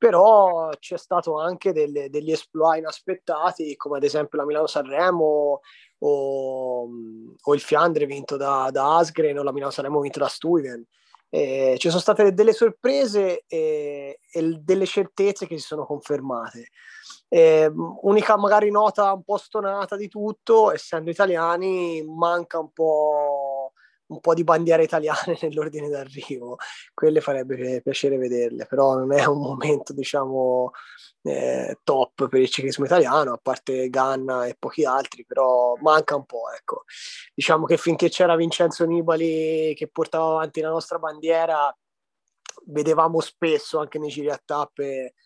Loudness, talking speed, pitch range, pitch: -22 LUFS, 145 wpm, 140-175 Hz, 155 Hz